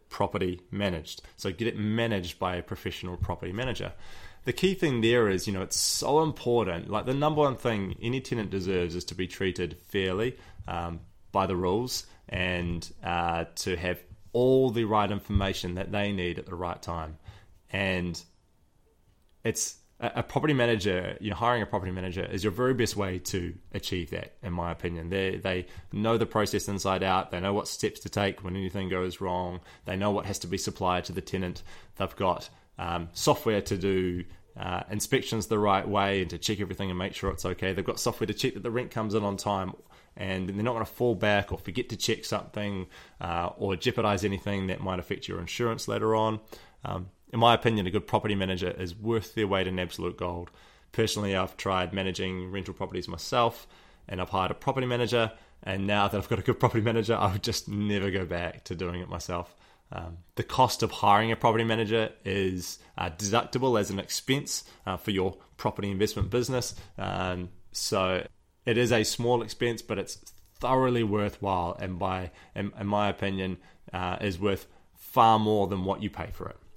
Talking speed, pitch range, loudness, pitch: 195 wpm, 90-110 Hz, -29 LUFS, 100 Hz